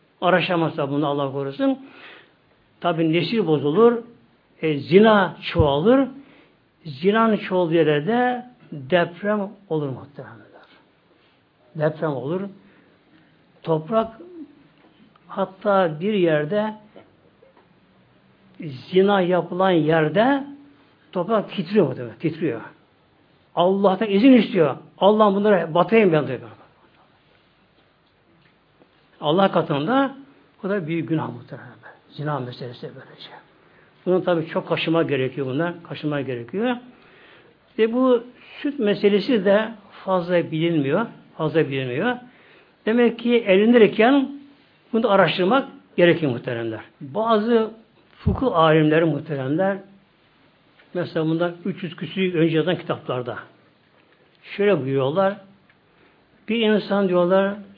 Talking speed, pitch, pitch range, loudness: 90 wpm, 185 Hz, 155-215 Hz, -21 LUFS